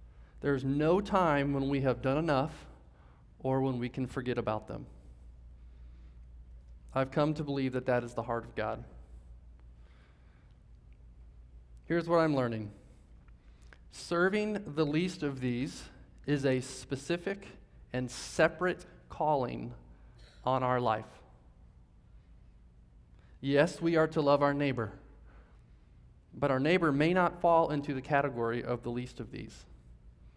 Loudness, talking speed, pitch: -32 LUFS, 130 wpm, 120 Hz